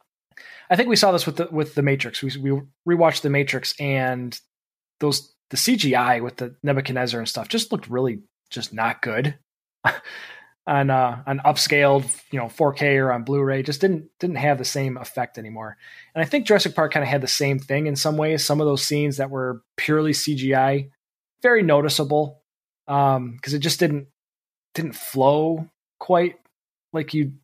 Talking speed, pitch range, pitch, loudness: 185 wpm, 135-155 Hz, 145 Hz, -21 LUFS